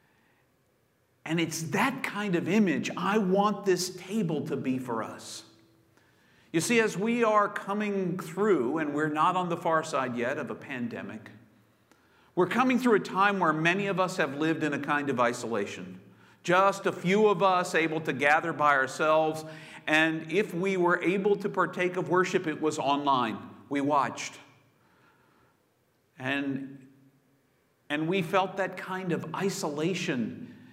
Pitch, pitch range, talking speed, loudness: 160 Hz, 140-190 Hz, 155 wpm, -28 LUFS